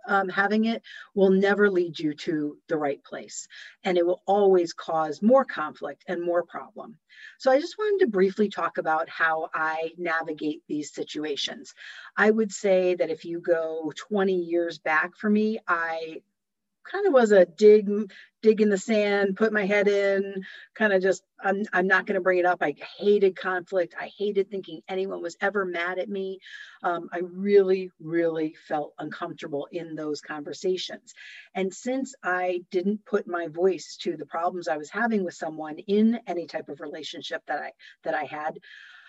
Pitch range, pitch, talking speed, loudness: 170-205 Hz, 185 Hz, 180 wpm, -25 LUFS